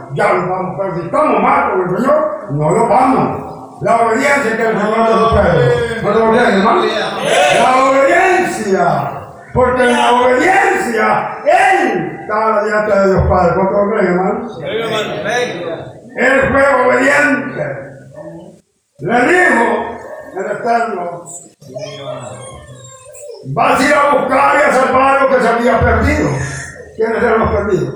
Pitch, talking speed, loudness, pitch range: 225 Hz, 135 wpm, -12 LUFS, 185-270 Hz